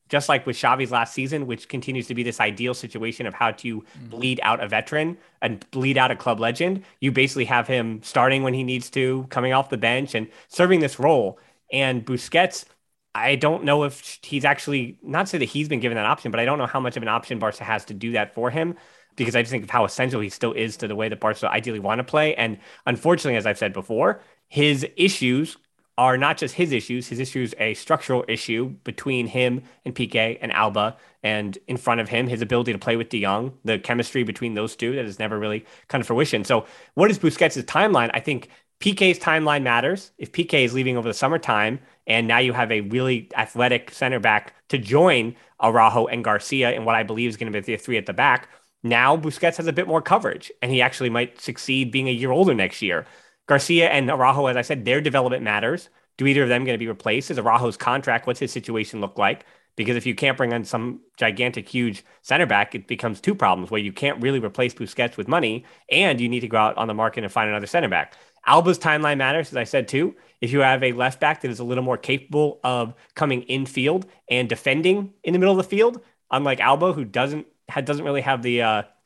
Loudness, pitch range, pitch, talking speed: -22 LUFS, 115-140 Hz, 125 Hz, 235 wpm